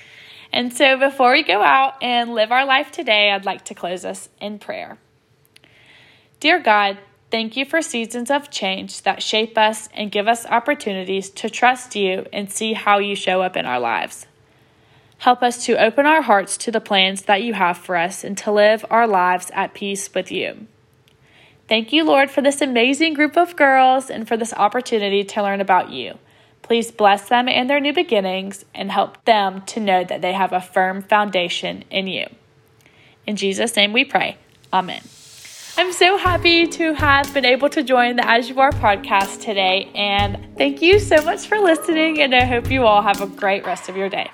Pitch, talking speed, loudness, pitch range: 215 Hz, 195 wpm, -17 LUFS, 195-265 Hz